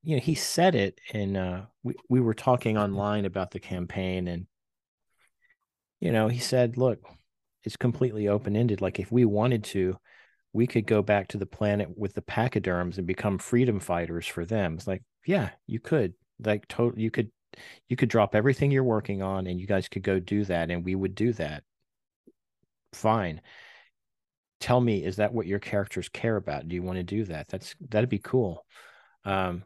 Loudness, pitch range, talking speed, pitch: -28 LUFS, 95-115 Hz, 190 wpm, 105 Hz